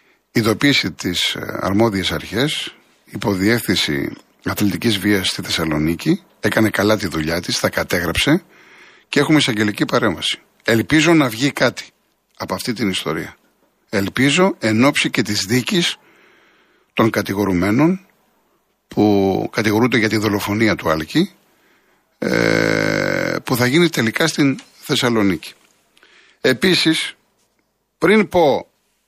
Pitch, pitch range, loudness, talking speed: 110 Hz, 100-145 Hz, -17 LUFS, 105 wpm